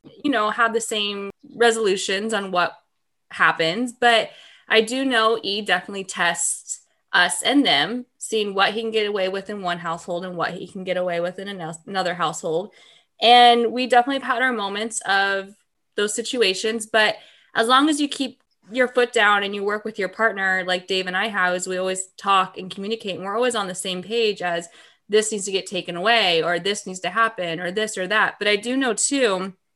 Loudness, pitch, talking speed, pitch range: -21 LUFS, 205 Hz, 210 wpm, 185-230 Hz